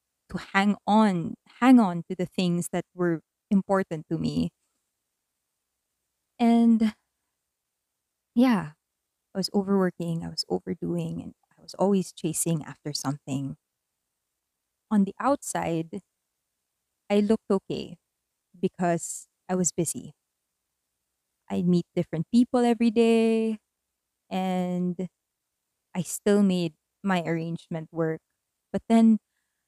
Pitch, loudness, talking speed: 170 Hz, -26 LUFS, 105 wpm